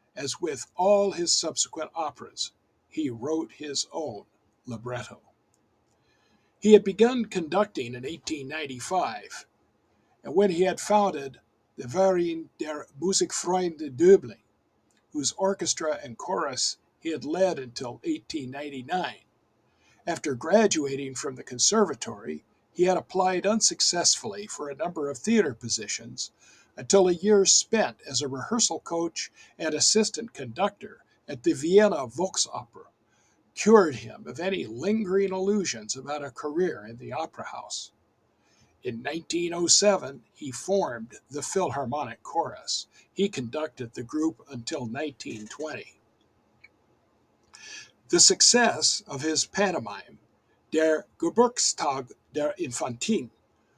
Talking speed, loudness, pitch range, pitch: 115 wpm, -26 LUFS, 135-200 Hz, 165 Hz